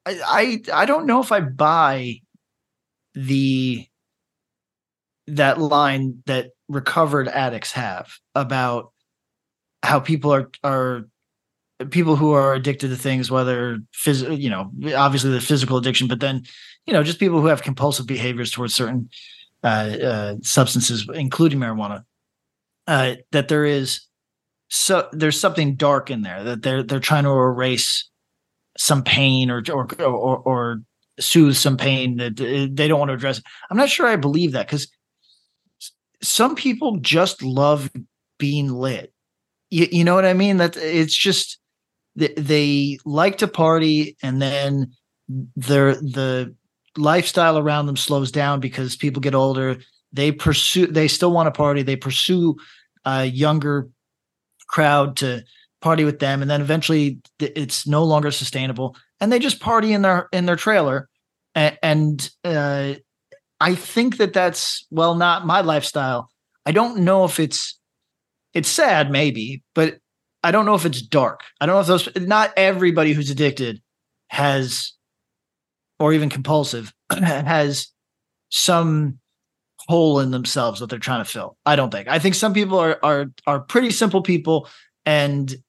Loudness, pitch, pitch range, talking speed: -19 LUFS, 145 Hz, 130-160 Hz, 150 wpm